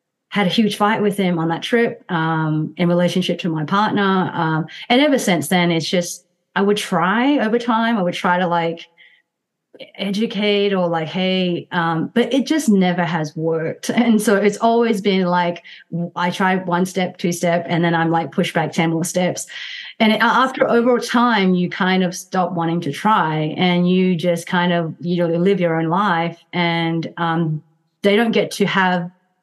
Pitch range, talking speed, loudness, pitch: 170-205 Hz, 190 wpm, -18 LUFS, 180 Hz